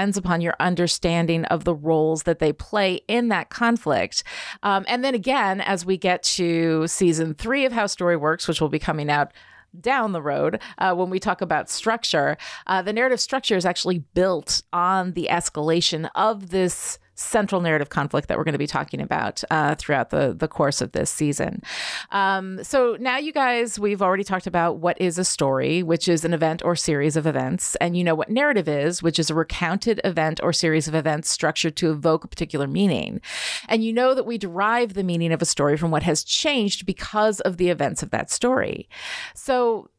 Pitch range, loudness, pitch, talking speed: 165-210 Hz, -22 LUFS, 180 Hz, 205 wpm